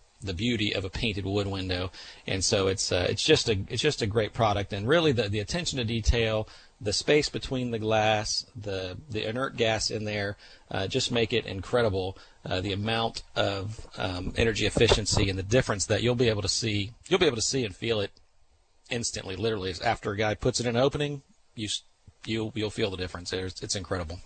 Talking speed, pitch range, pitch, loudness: 210 wpm, 95-115 Hz, 110 Hz, -28 LUFS